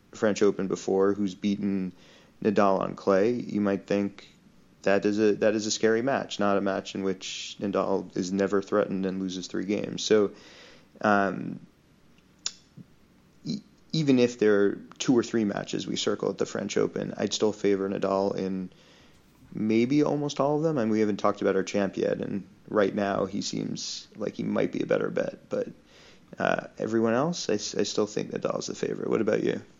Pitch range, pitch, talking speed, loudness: 95-110 Hz, 100 Hz, 190 wpm, -27 LUFS